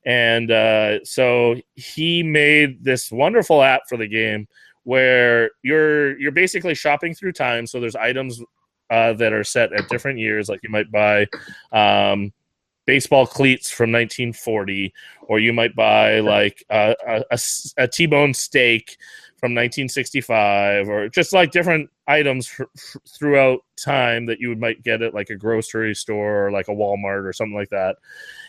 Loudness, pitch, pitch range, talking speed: -18 LUFS, 120 Hz, 110-140 Hz, 160 wpm